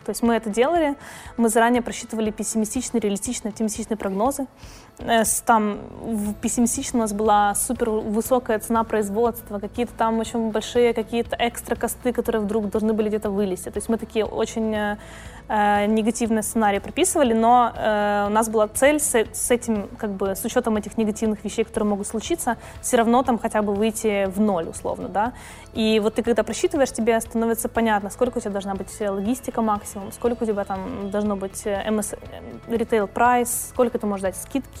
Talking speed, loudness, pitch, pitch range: 175 wpm, -22 LUFS, 225 Hz, 210-235 Hz